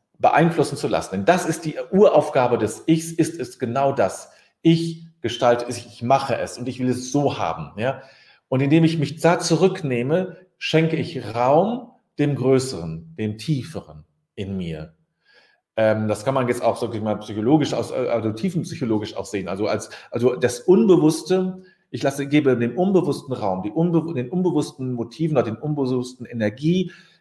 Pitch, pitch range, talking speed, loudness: 135 Hz, 115-165 Hz, 170 wpm, -21 LUFS